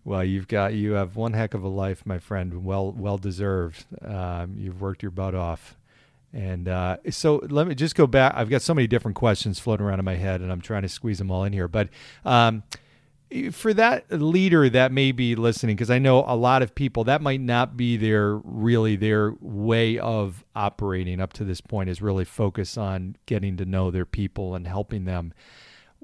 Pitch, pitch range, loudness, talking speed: 105 Hz, 95-120 Hz, -24 LUFS, 210 wpm